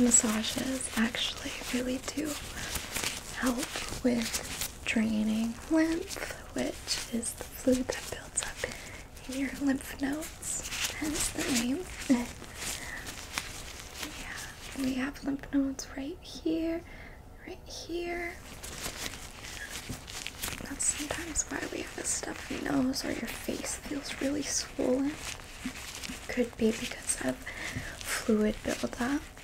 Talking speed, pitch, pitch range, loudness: 105 wpm, 265 Hz, 245-295 Hz, -33 LUFS